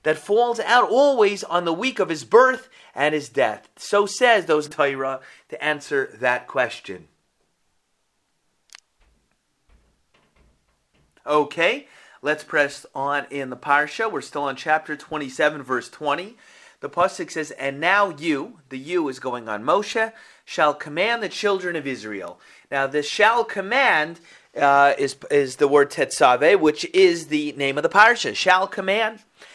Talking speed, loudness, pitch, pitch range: 145 wpm, -21 LUFS, 155 Hz, 145-210 Hz